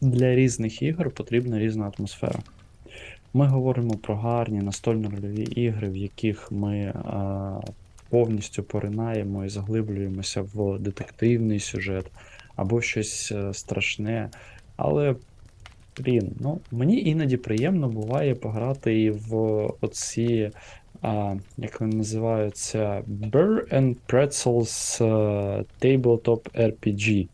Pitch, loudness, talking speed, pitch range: 110 Hz, -25 LUFS, 100 wpm, 100-120 Hz